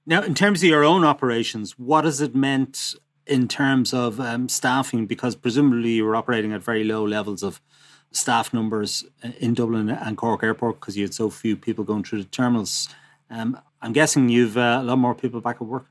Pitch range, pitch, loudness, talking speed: 110-135 Hz, 120 Hz, -22 LUFS, 210 wpm